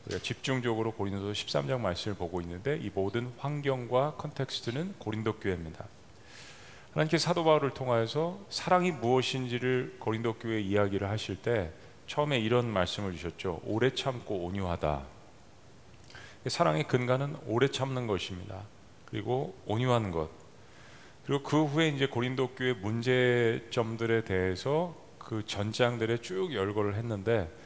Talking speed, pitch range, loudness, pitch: 320 characters per minute, 100-130 Hz, -31 LUFS, 115 Hz